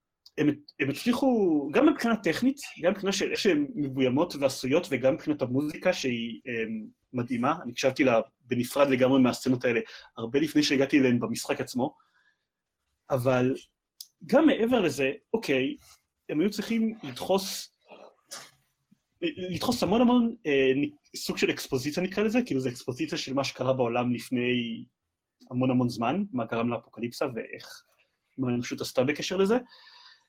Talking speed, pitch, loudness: 140 wpm, 145 Hz, -27 LUFS